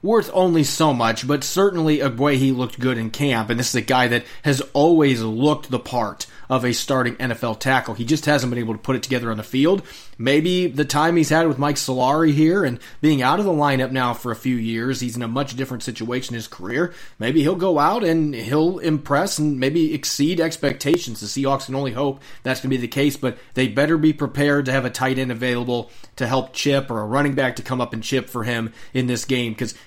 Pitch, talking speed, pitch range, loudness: 130 Hz, 240 wpm, 125-150 Hz, -20 LUFS